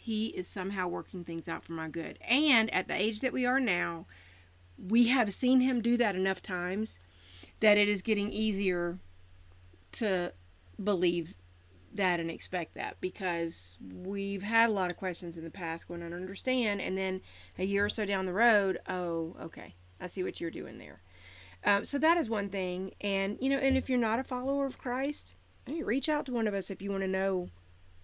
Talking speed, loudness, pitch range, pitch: 205 wpm, -31 LUFS, 165-215 Hz, 190 Hz